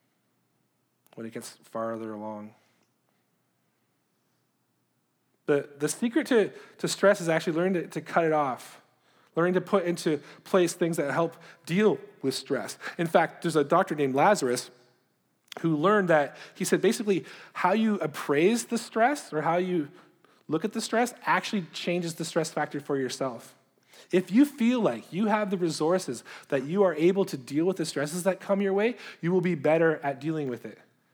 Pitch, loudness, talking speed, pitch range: 170 Hz, -27 LUFS, 175 wpm, 150-195 Hz